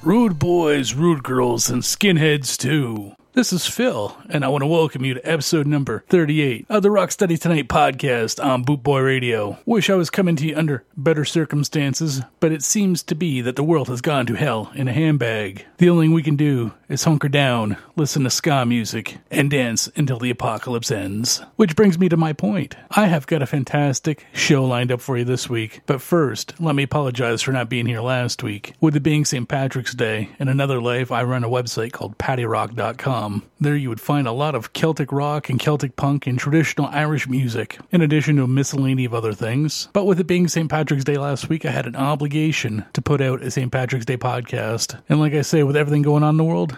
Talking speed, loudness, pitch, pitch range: 220 wpm, -20 LUFS, 140 Hz, 125-160 Hz